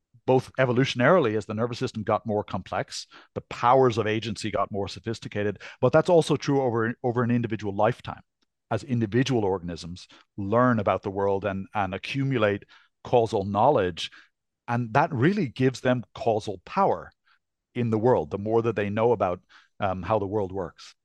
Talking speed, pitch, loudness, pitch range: 165 wpm, 115 Hz, -25 LUFS, 105-125 Hz